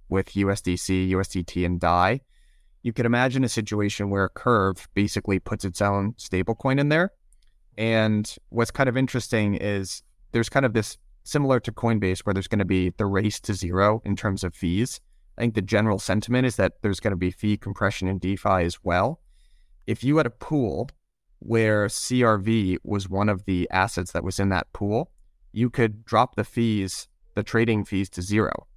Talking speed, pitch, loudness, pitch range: 190 wpm, 105 Hz, -24 LUFS, 95-115 Hz